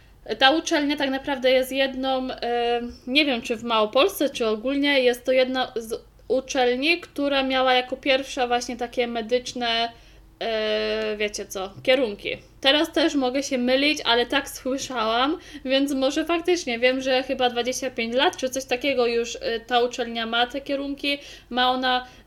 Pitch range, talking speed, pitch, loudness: 240-275 Hz, 150 wpm, 255 Hz, -23 LUFS